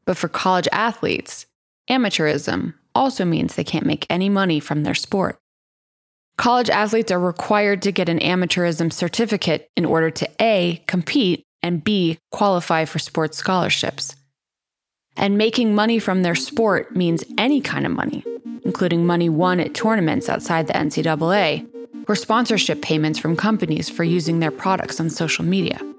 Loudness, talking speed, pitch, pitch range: -20 LUFS, 150 wpm, 180 Hz, 165-215 Hz